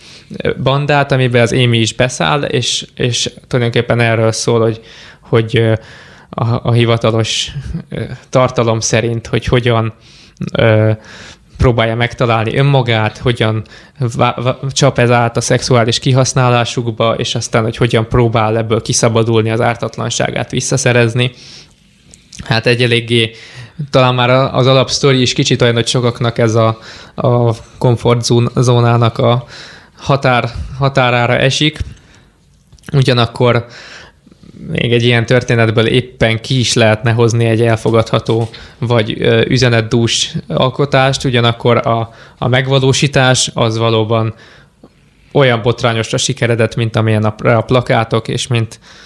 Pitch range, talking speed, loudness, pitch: 115-130 Hz, 110 wpm, -13 LUFS, 120 Hz